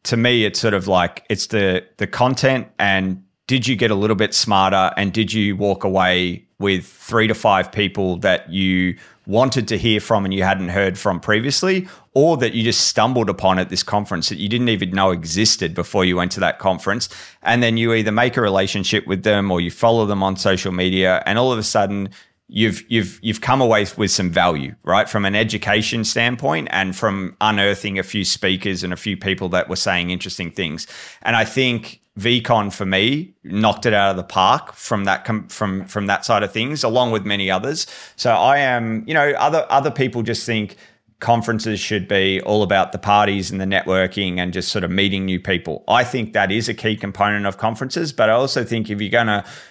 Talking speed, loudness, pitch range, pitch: 215 wpm, -18 LUFS, 95-115 Hz, 105 Hz